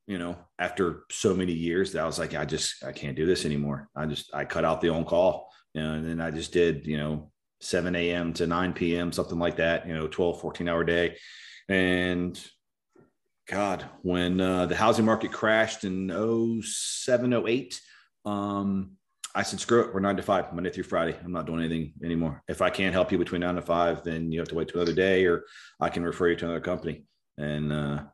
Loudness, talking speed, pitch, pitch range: -28 LUFS, 220 wpm, 85 Hz, 80-95 Hz